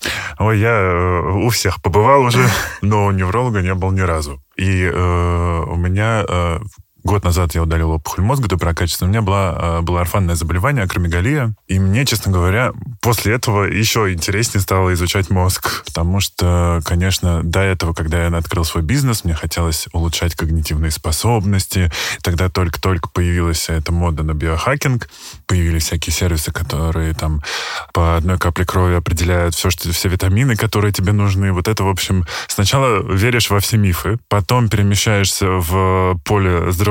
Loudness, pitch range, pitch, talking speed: -16 LUFS, 85-105 Hz, 95 Hz, 160 wpm